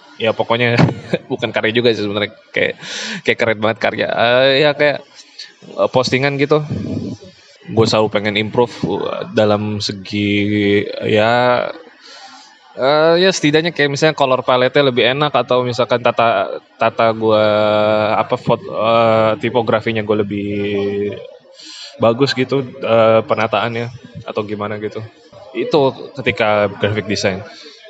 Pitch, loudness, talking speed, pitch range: 115 Hz, -15 LUFS, 120 wpm, 105-130 Hz